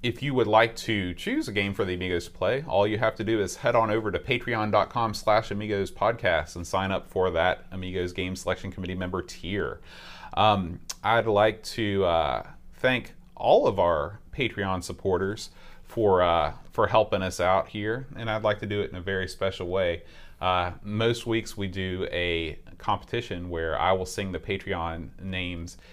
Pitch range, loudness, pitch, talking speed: 90-105 Hz, -27 LUFS, 95 Hz, 185 wpm